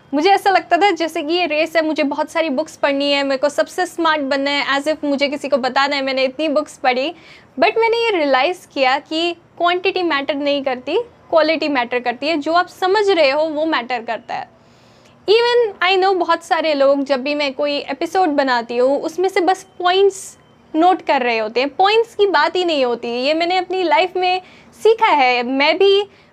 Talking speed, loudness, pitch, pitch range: 210 wpm, -17 LUFS, 315 Hz, 280-365 Hz